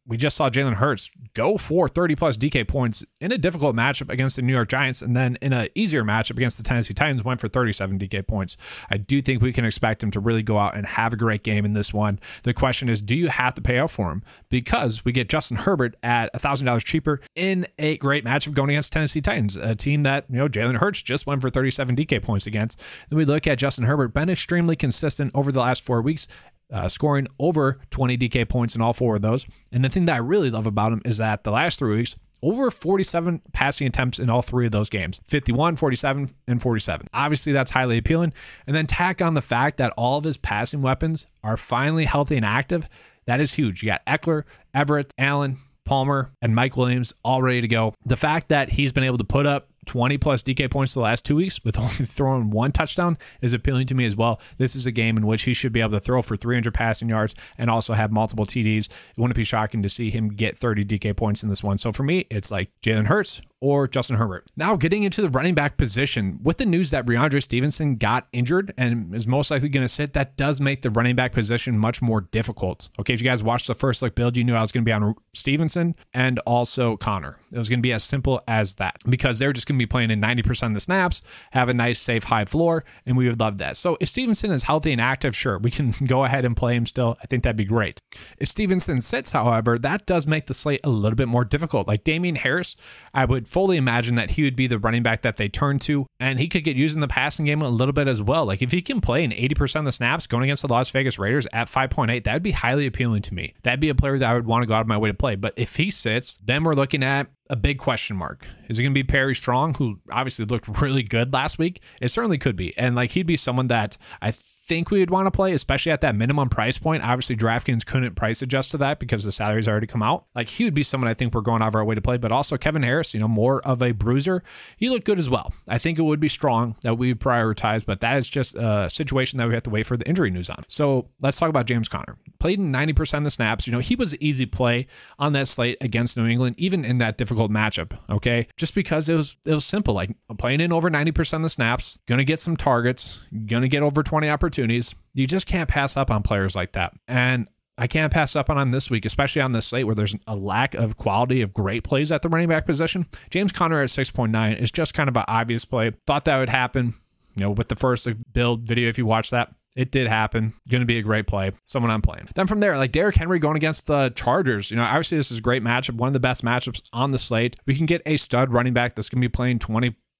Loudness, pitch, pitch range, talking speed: -22 LUFS, 125 Hz, 115-145 Hz, 260 wpm